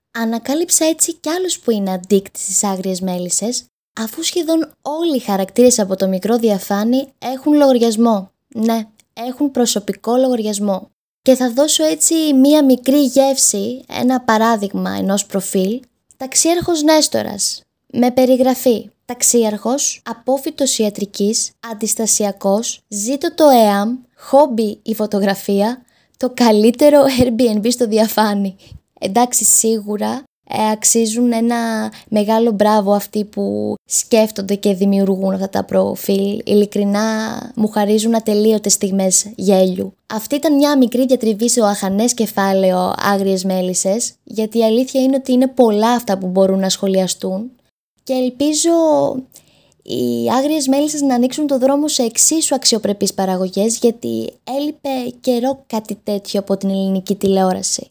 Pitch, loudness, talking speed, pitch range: 225 Hz, -15 LUFS, 125 wpm, 200-260 Hz